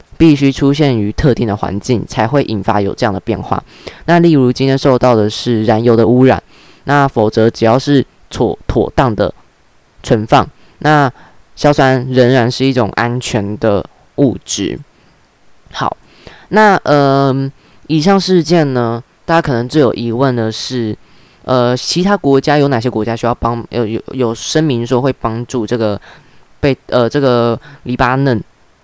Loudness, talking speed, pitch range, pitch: -13 LUFS, 225 characters per minute, 115-140 Hz, 125 Hz